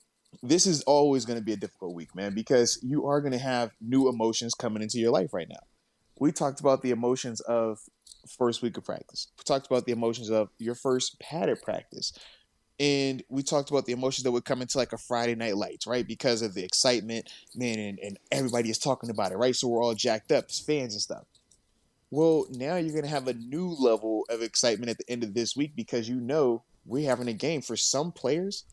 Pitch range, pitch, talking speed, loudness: 115-135 Hz, 120 Hz, 225 wpm, -28 LUFS